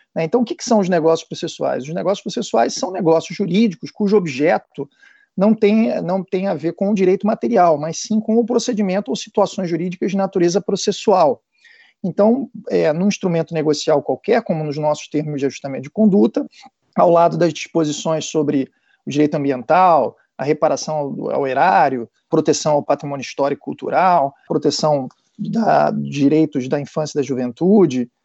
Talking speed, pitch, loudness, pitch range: 165 wpm, 175 Hz, -18 LUFS, 150-210 Hz